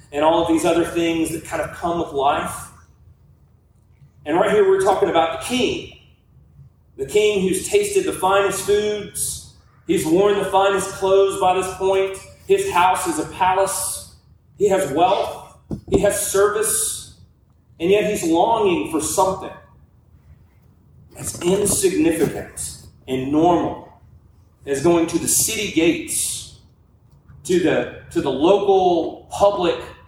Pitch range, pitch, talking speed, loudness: 165-205 Hz, 190 Hz, 135 wpm, -19 LUFS